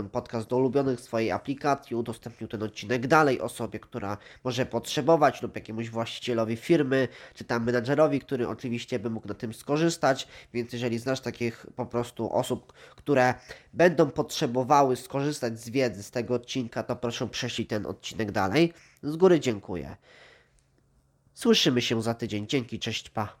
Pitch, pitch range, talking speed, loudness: 120 Hz, 115-135 Hz, 150 wpm, -28 LUFS